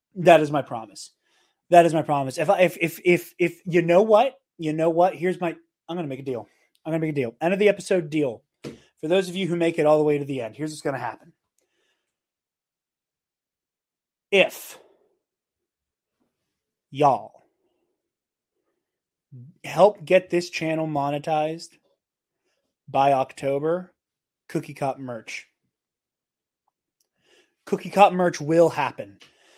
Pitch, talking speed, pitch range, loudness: 165 Hz, 145 wpm, 145-175 Hz, -22 LUFS